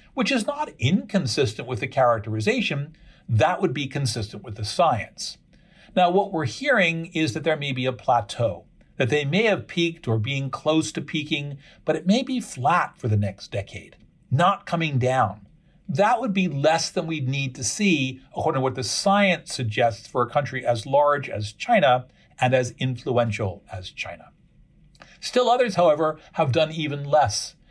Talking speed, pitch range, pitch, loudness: 175 wpm, 125-170 Hz, 150 Hz, -23 LUFS